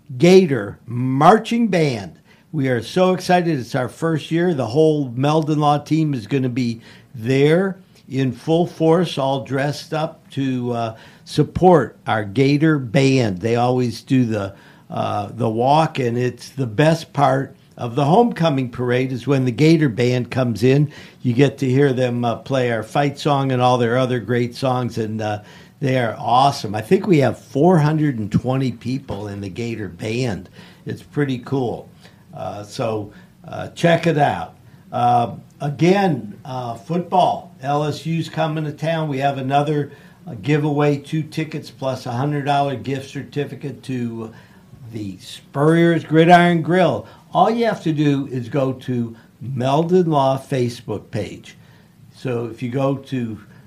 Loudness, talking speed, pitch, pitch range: -19 LUFS, 155 wpm, 135 Hz, 120-155 Hz